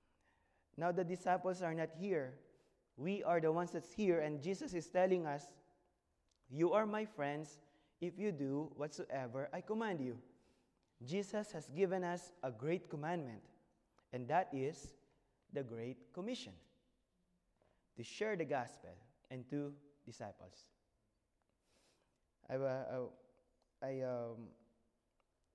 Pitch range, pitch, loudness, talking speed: 130-180 Hz, 150 Hz, -42 LUFS, 120 wpm